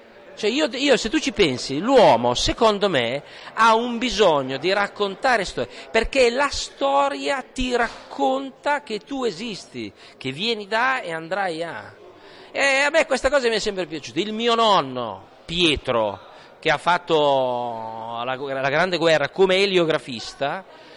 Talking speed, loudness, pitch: 150 wpm, -21 LUFS, 205 Hz